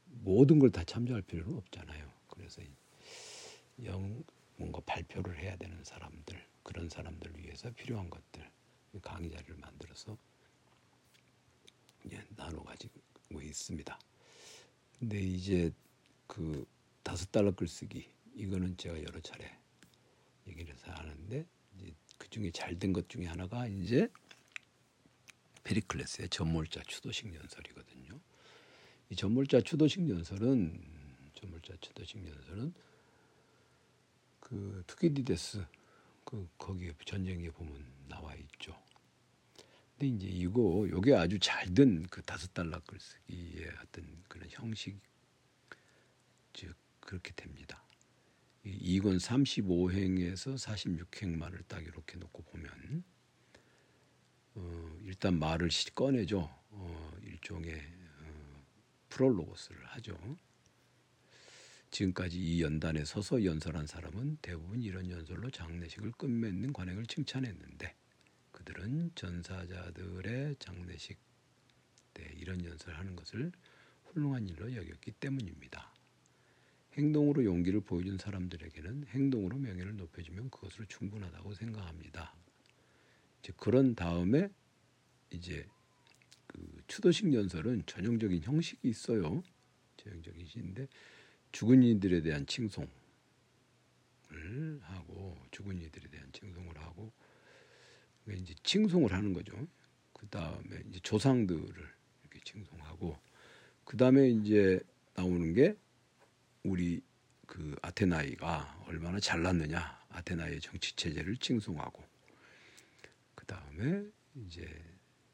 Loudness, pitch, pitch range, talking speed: -35 LUFS, 95 Hz, 85-110 Hz, 245 characters per minute